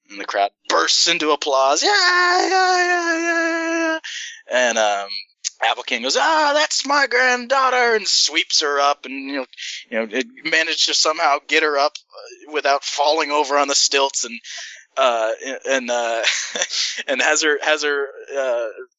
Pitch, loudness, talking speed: 155 Hz, -18 LUFS, 160 wpm